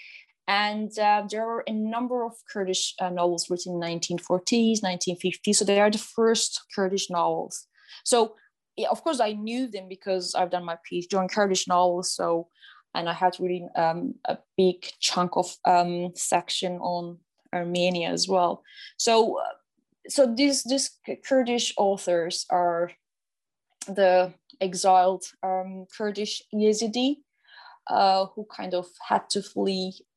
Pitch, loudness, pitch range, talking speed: 190 Hz, -25 LUFS, 180-225 Hz, 140 wpm